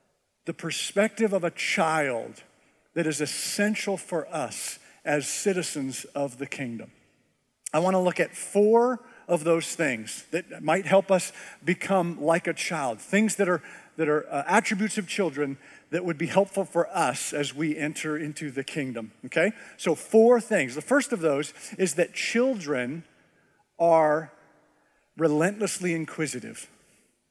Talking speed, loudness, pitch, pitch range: 145 wpm, -26 LUFS, 170 Hz, 150-195 Hz